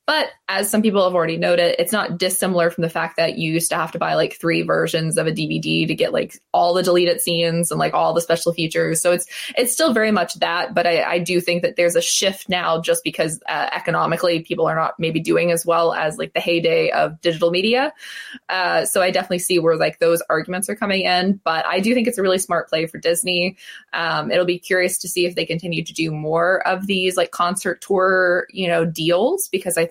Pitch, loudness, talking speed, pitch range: 175 Hz, -19 LUFS, 240 wpm, 165-185 Hz